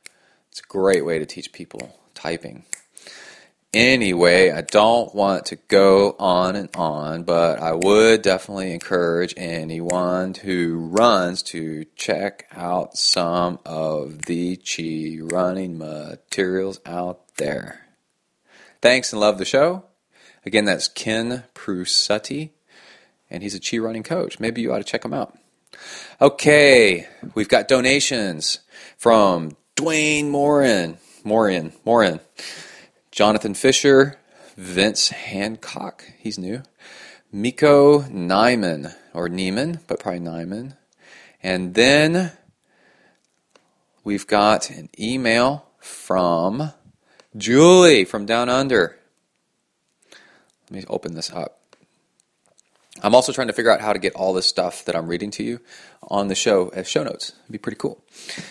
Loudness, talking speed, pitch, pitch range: -19 LUFS, 125 wpm, 95 Hz, 85-120 Hz